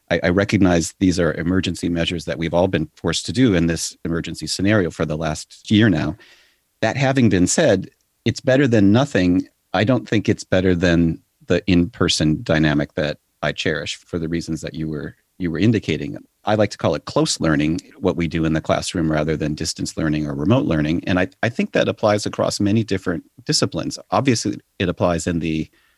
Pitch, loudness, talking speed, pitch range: 90 Hz, -20 LUFS, 200 wpm, 80-100 Hz